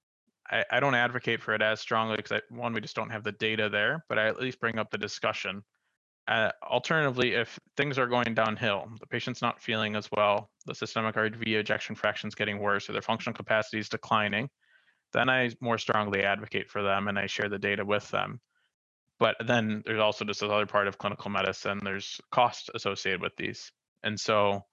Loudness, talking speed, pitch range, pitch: -29 LUFS, 200 wpm, 105-115 Hz, 110 Hz